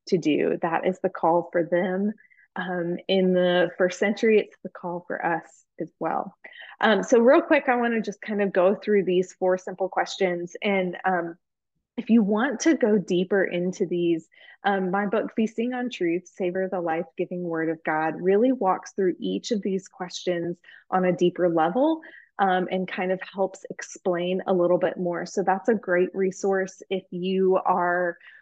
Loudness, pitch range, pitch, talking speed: -24 LUFS, 180-205 Hz, 185 Hz, 185 wpm